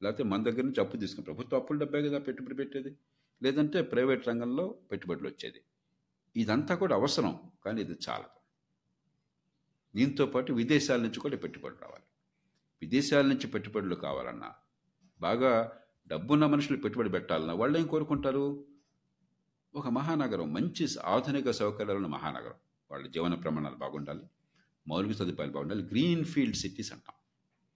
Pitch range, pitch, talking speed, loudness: 105-145 Hz, 135 Hz, 125 wpm, -32 LUFS